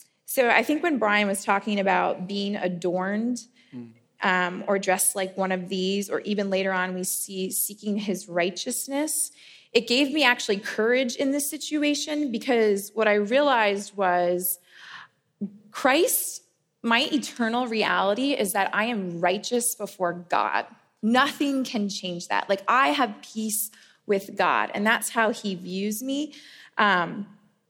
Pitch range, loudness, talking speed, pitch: 190-245 Hz, -24 LUFS, 145 wpm, 205 Hz